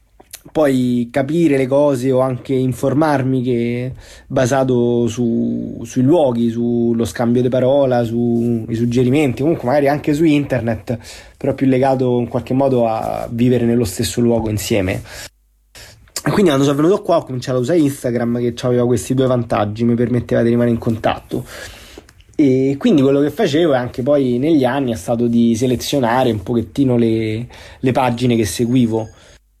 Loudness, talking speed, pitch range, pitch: -16 LUFS, 155 wpm, 115-135 Hz, 125 Hz